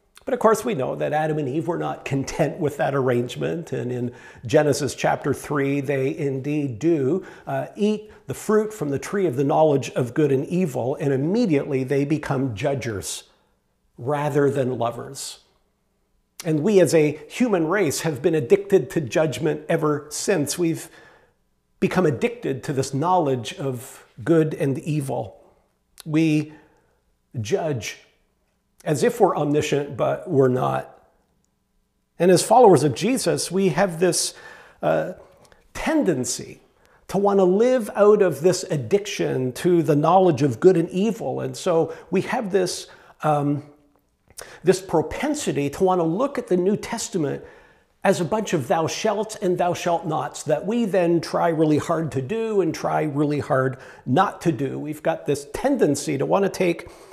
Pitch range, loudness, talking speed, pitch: 140-190 Hz, -22 LUFS, 160 wpm, 160 Hz